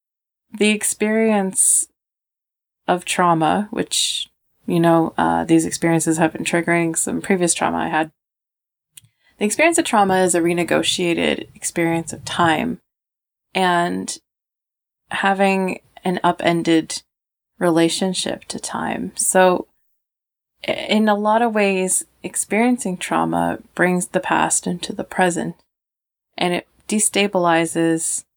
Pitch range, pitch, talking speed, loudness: 165-200 Hz, 175 Hz, 110 wpm, -19 LUFS